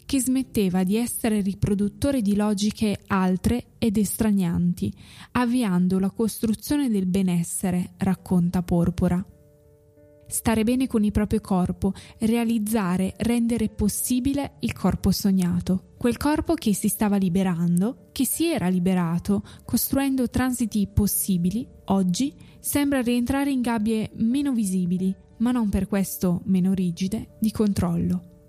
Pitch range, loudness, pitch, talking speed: 185-235 Hz, -24 LUFS, 210 Hz, 120 wpm